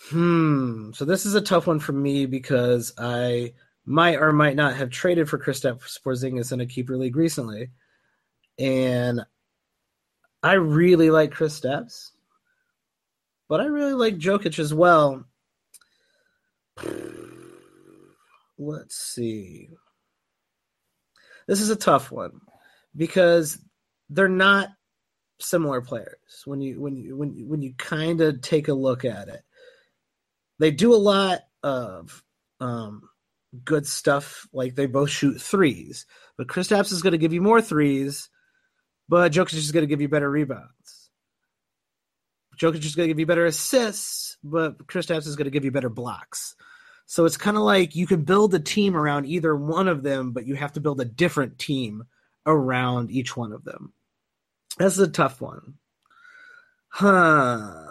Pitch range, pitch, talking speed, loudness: 135-190 Hz, 155 Hz, 155 wpm, -22 LUFS